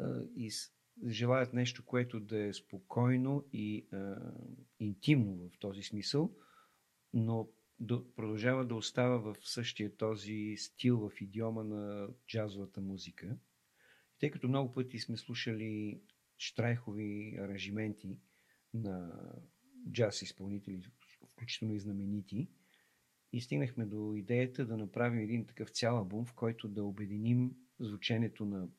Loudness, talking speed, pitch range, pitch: -38 LUFS, 120 wpm, 100-120 Hz, 110 Hz